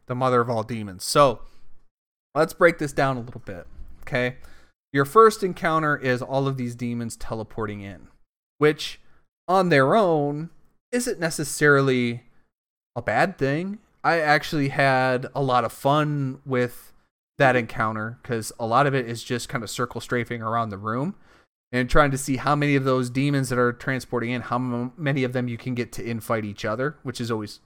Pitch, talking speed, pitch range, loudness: 125 Hz, 185 wpm, 115-145 Hz, -23 LUFS